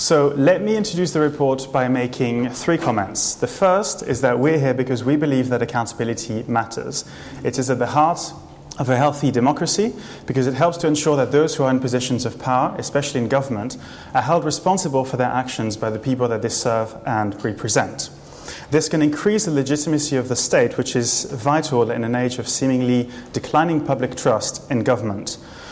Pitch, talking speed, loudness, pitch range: 130 Hz, 190 wpm, -20 LUFS, 120-150 Hz